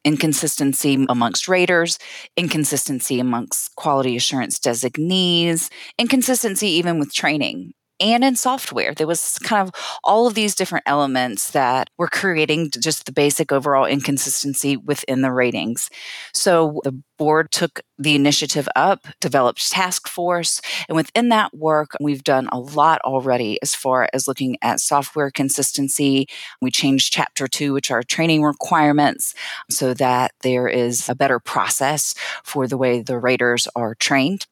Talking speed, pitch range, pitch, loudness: 145 wpm, 130-165 Hz, 145 Hz, -19 LUFS